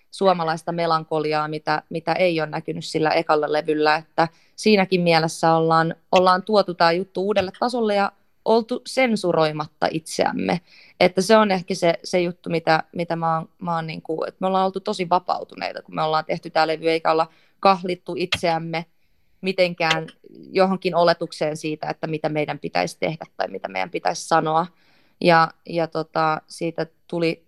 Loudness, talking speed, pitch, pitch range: -22 LUFS, 160 wpm, 165 Hz, 160-185 Hz